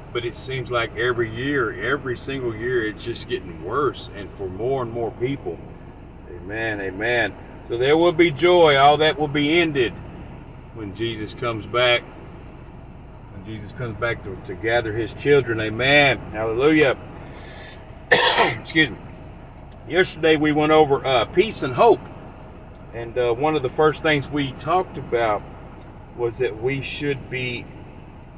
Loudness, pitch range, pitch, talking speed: -21 LUFS, 115-145 Hz, 125 Hz, 150 wpm